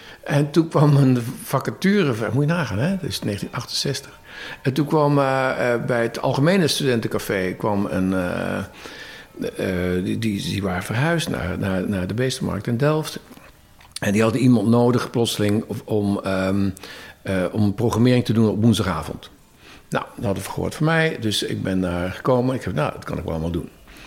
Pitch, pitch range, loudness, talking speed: 115 Hz, 100-135 Hz, -21 LUFS, 180 wpm